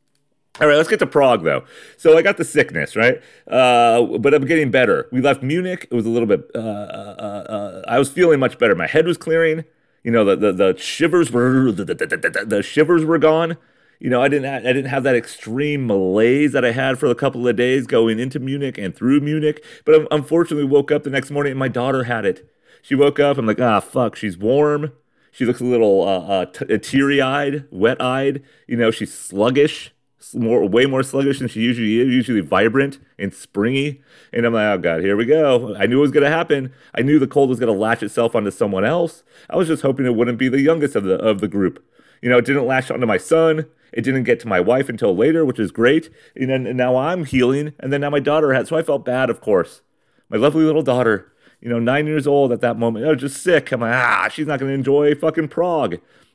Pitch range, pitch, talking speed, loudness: 120-150 Hz, 135 Hz, 240 wpm, -17 LUFS